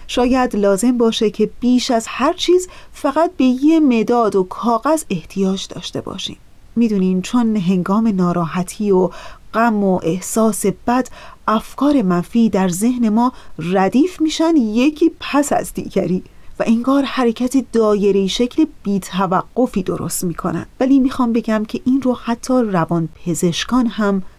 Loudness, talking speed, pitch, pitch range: -17 LUFS, 135 wpm, 230 Hz, 195-255 Hz